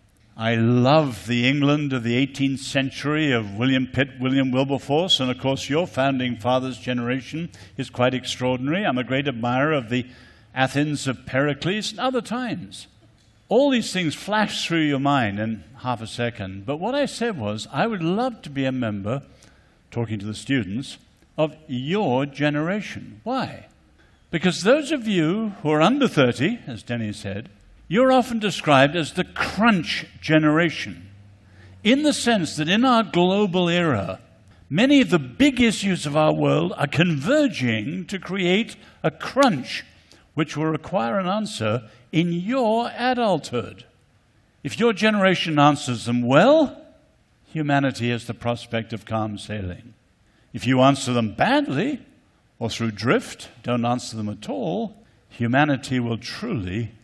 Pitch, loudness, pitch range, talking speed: 135 Hz, -22 LUFS, 120-180 Hz, 150 wpm